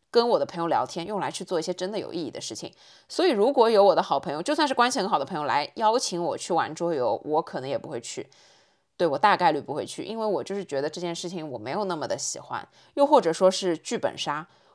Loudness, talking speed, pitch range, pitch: -25 LUFS, 370 characters per minute, 170-230 Hz, 190 Hz